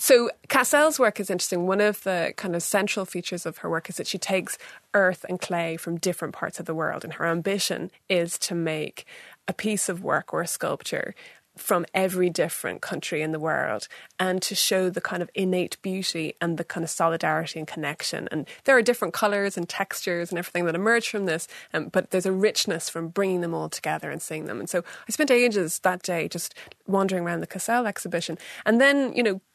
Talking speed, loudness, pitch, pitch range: 215 wpm, -25 LUFS, 185 Hz, 170-200 Hz